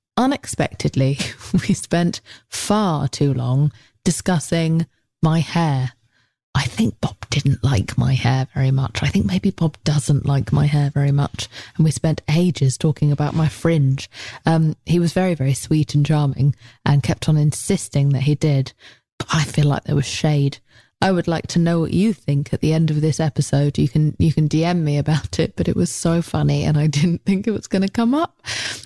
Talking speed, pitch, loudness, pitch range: 200 wpm, 150 Hz, -19 LUFS, 135-165 Hz